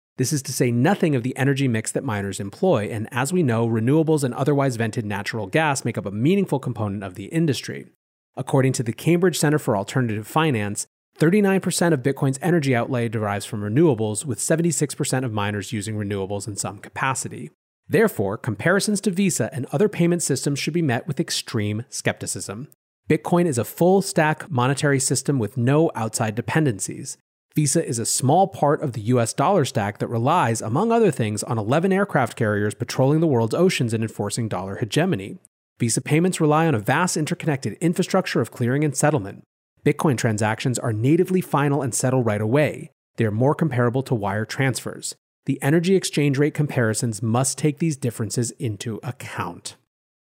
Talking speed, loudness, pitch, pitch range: 175 wpm, -22 LUFS, 135 Hz, 115-155 Hz